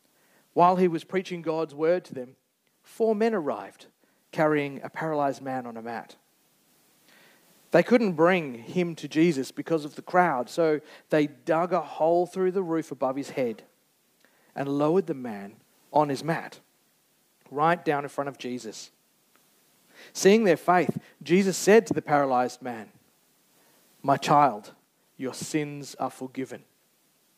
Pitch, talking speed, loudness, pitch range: 155 Hz, 145 wpm, -26 LUFS, 135-175 Hz